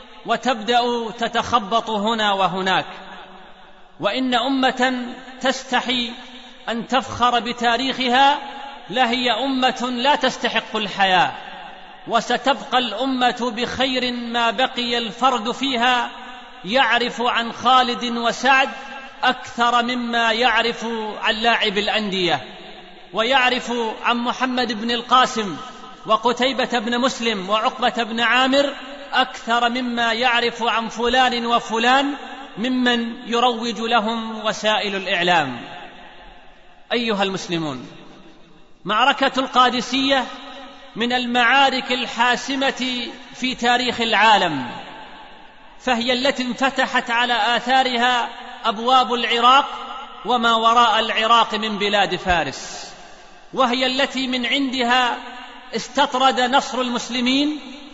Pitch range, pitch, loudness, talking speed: 230-255 Hz, 245 Hz, -19 LUFS, 85 wpm